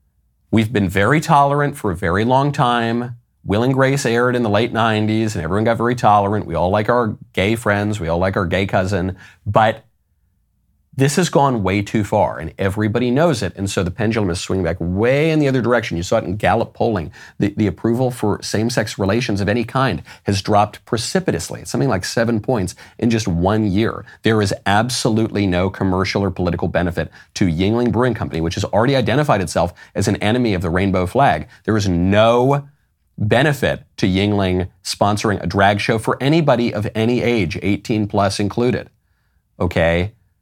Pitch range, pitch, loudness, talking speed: 95-120 Hz, 105 Hz, -18 LUFS, 185 wpm